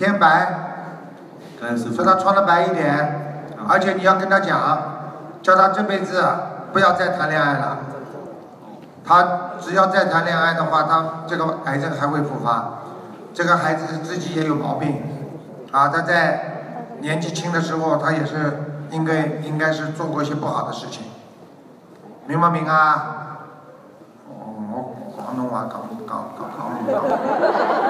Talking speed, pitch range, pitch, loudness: 210 characters per minute, 150-175 Hz, 155 Hz, -19 LUFS